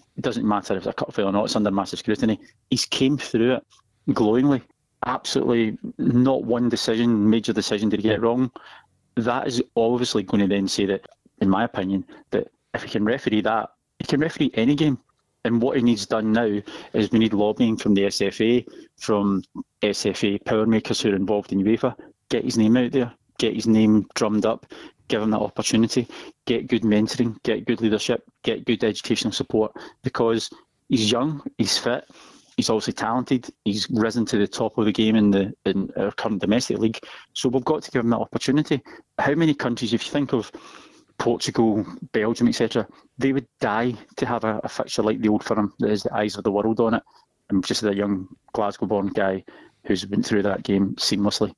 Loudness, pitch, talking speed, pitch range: -23 LUFS, 110 Hz, 200 wpm, 105-120 Hz